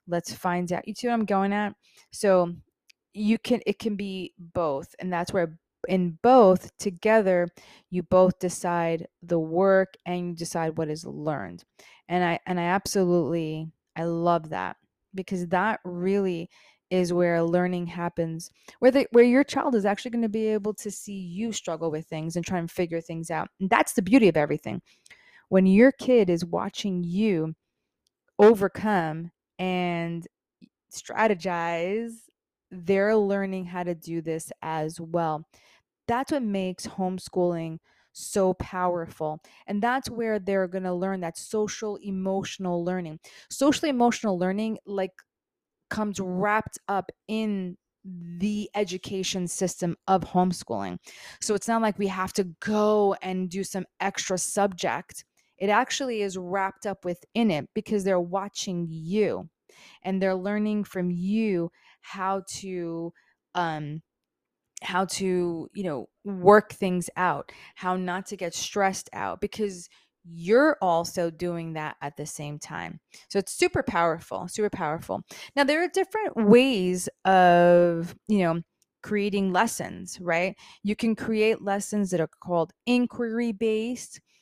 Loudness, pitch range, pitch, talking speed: -26 LUFS, 175-210 Hz, 190 Hz, 145 wpm